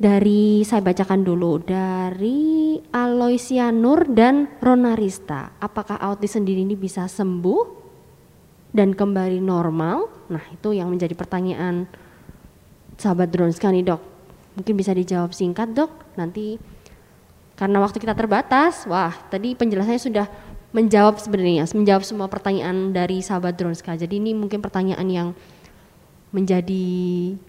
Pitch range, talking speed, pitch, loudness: 180-215 Hz, 120 wpm, 195 Hz, -21 LUFS